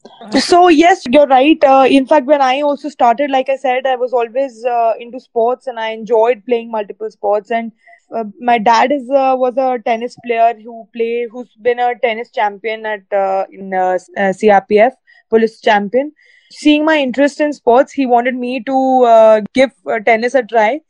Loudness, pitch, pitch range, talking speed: -13 LUFS, 245 Hz, 225-270 Hz, 190 wpm